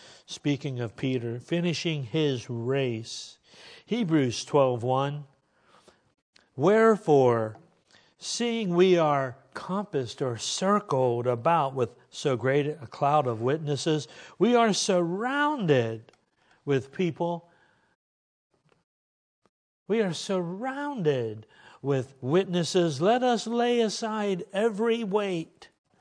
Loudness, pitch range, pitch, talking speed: -27 LUFS, 130-195 Hz, 150 Hz, 90 wpm